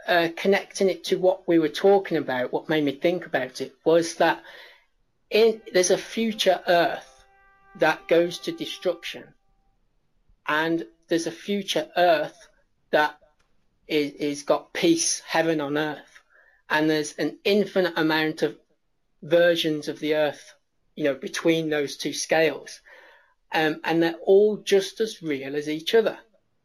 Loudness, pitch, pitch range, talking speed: -24 LUFS, 165 Hz, 155-190 Hz, 145 wpm